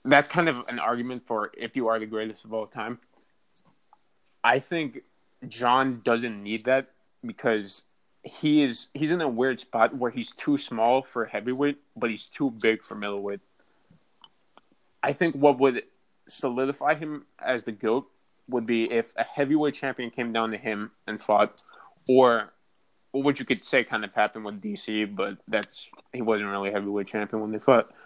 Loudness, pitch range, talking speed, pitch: -26 LUFS, 110-140 Hz, 175 wpm, 120 Hz